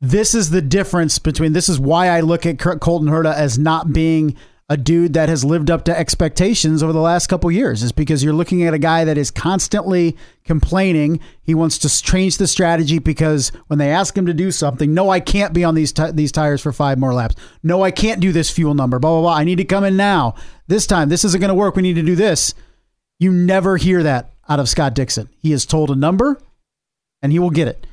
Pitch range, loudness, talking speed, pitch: 150-180 Hz, -16 LUFS, 245 wpm, 165 Hz